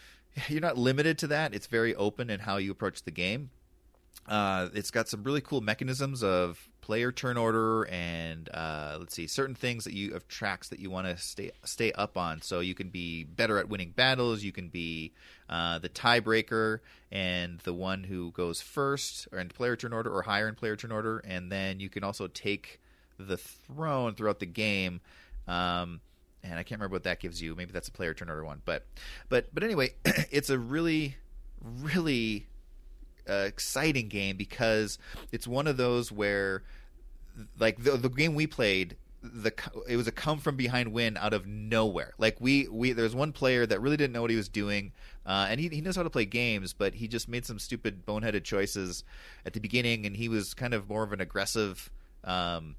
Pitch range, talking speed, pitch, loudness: 90-120 Hz, 205 wpm, 105 Hz, -31 LUFS